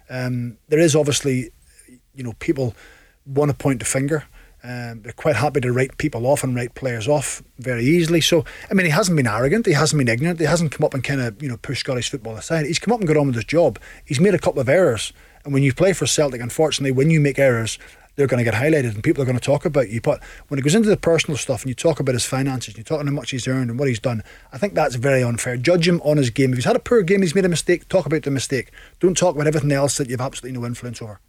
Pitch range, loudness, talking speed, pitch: 125-155 Hz, -20 LUFS, 285 wpm, 140 Hz